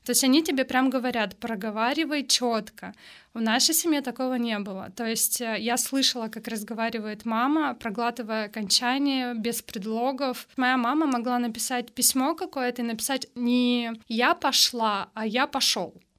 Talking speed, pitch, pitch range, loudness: 145 wpm, 245 Hz, 225-260 Hz, -25 LUFS